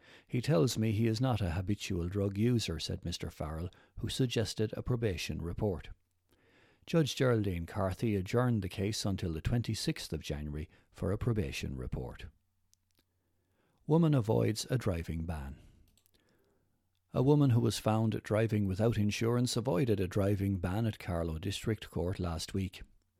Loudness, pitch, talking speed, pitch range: -33 LUFS, 100 Hz, 145 wpm, 90-115 Hz